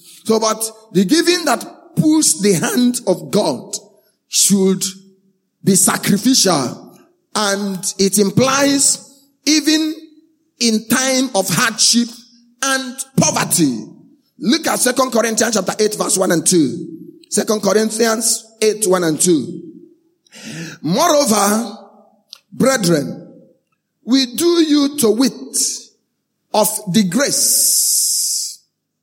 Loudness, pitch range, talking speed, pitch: -15 LUFS, 205-270 Hz, 100 wpm, 225 Hz